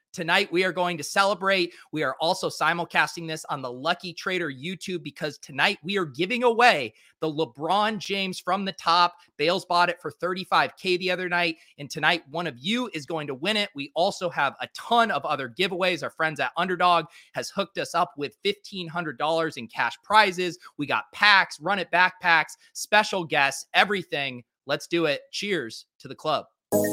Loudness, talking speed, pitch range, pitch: -25 LUFS, 185 wpm, 160-190 Hz, 175 Hz